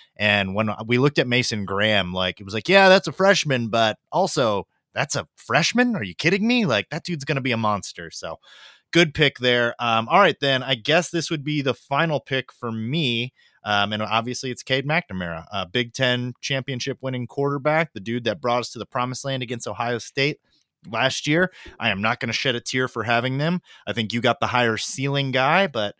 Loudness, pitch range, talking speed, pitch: -22 LUFS, 115-150 Hz, 220 wpm, 125 Hz